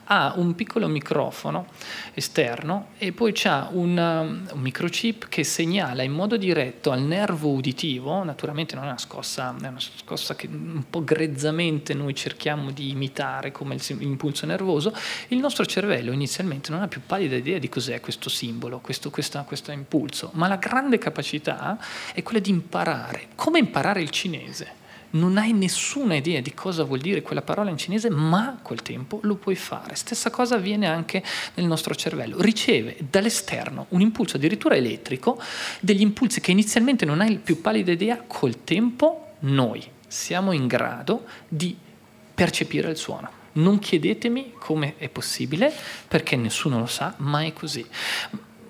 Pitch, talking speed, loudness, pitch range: 170 Hz, 160 wpm, -25 LUFS, 145-210 Hz